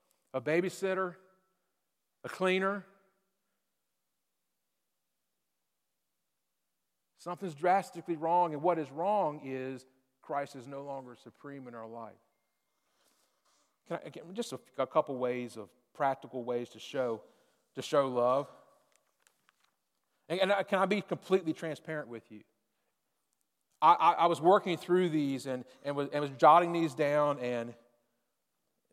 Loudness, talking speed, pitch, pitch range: -31 LUFS, 130 wpm, 145 Hz, 125-175 Hz